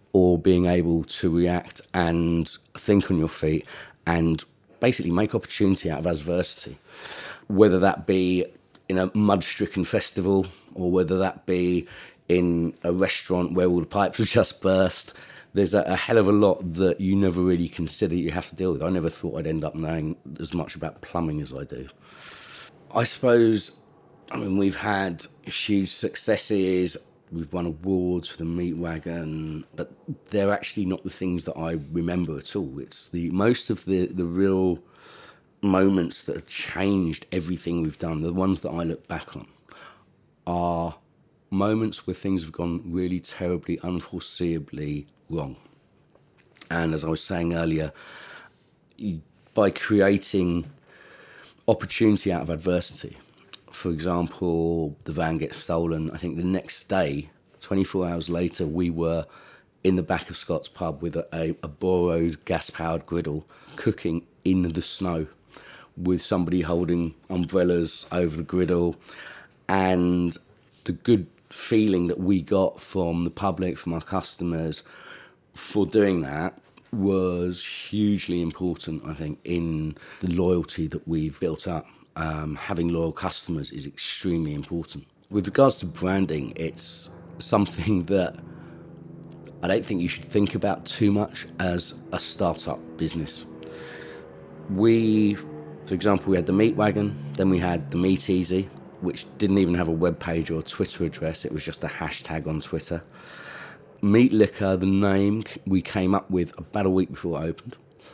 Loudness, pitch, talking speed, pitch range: -25 LUFS, 90 Hz, 155 wpm, 80-95 Hz